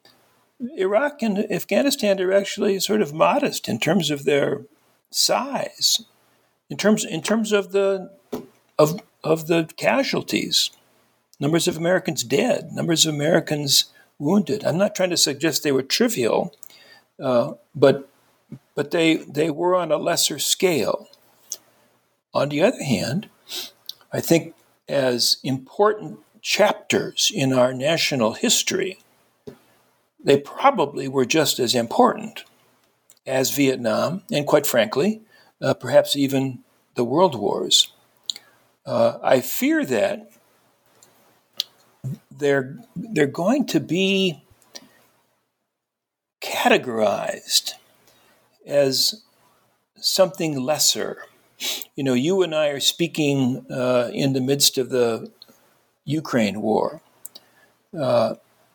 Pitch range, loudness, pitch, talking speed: 140-200 Hz, -21 LUFS, 160 Hz, 110 wpm